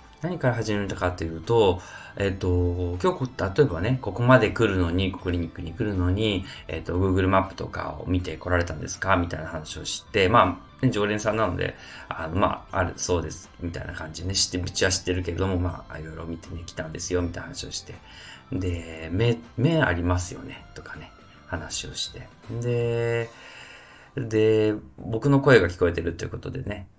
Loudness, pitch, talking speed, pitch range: -25 LUFS, 95 Hz, 375 characters per minute, 85-110 Hz